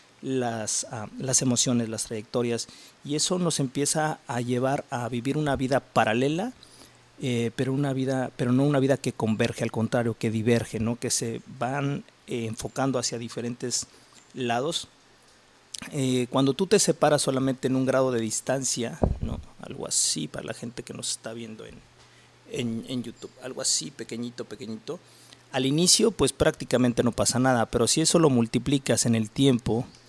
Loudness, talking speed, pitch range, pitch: -26 LUFS, 170 wpm, 115-135 Hz, 125 Hz